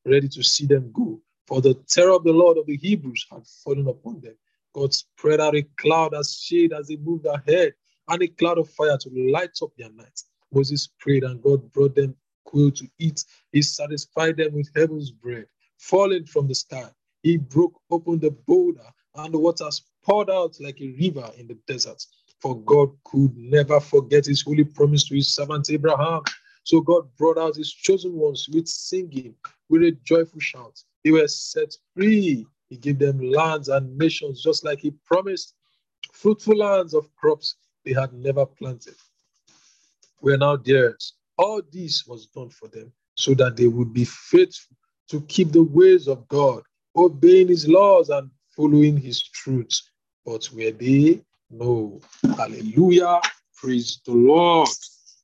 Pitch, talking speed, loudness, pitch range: 150 Hz, 170 wpm, -20 LUFS, 135-170 Hz